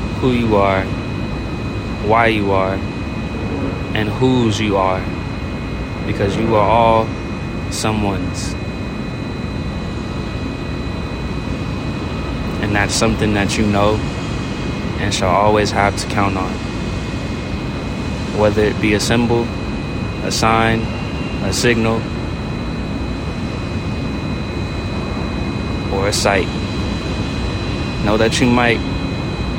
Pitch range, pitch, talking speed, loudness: 95-110 Hz, 105 Hz, 90 wpm, -18 LUFS